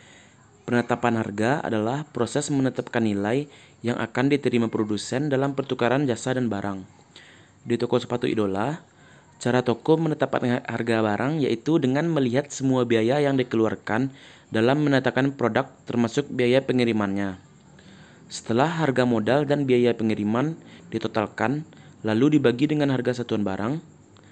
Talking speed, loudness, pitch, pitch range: 125 wpm, -24 LUFS, 125 Hz, 110-140 Hz